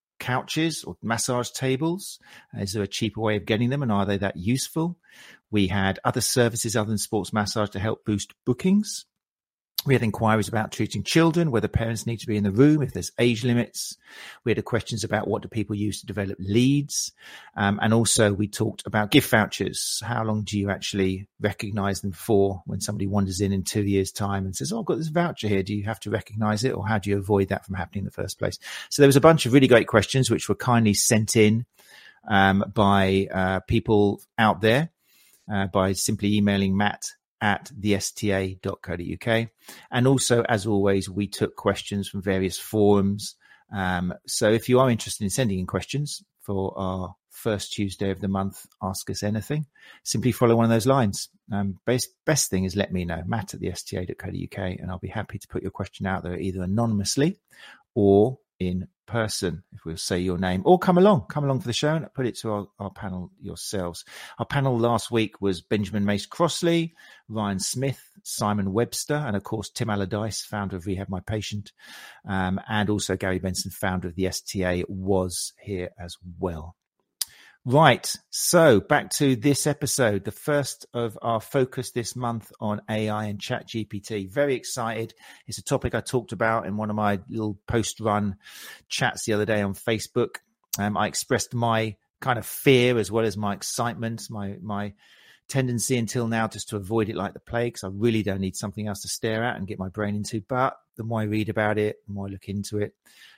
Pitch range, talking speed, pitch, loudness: 100-120 Hz, 200 wpm, 105 Hz, -25 LUFS